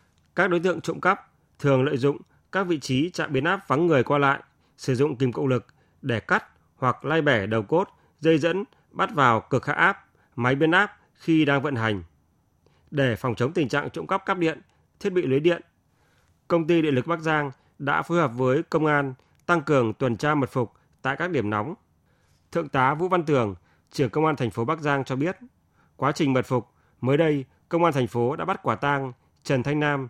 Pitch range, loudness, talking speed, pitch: 125-165 Hz, -24 LUFS, 220 wpm, 140 Hz